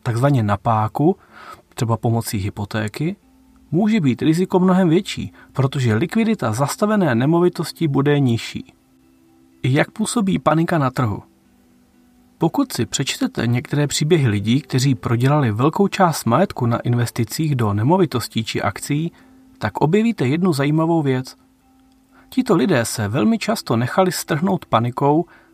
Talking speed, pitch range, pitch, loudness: 120 wpm, 115-185 Hz, 145 Hz, -19 LUFS